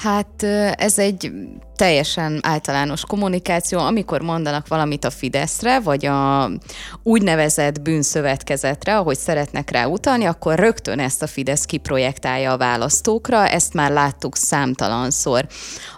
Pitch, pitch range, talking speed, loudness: 155 Hz, 140-200 Hz, 115 wpm, -19 LUFS